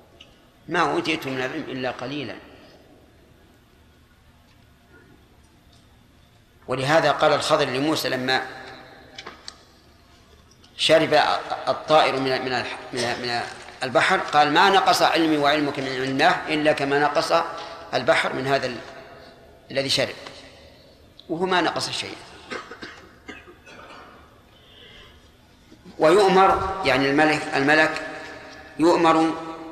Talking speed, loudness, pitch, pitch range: 80 wpm, -21 LUFS, 140 Hz, 130-155 Hz